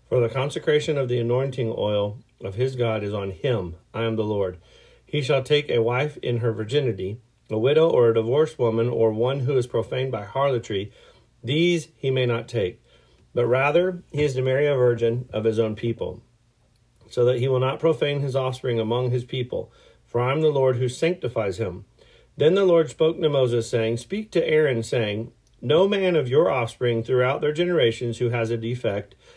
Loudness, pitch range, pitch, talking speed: -23 LUFS, 115-140 Hz, 125 Hz, 200 wpm